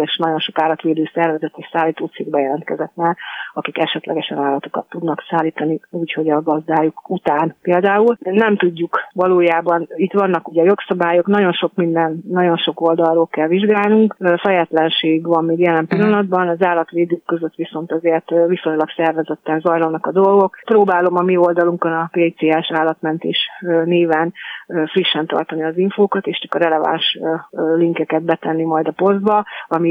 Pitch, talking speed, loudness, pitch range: 165 Hz, 140 wpm, -17 LUFS, 160-180 Hz